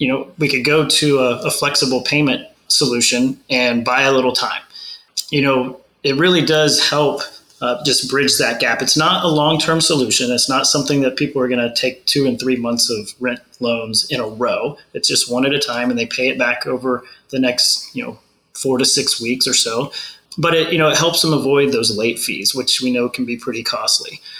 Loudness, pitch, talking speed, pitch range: -16 LUFS, 130 Hz, 225 wpm, 125-145 Hz